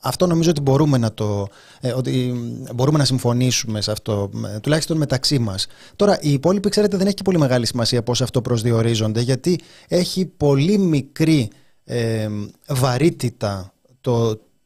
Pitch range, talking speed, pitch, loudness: 115-155 Hz, 145 wpm, 130 Hz, -19 LUFS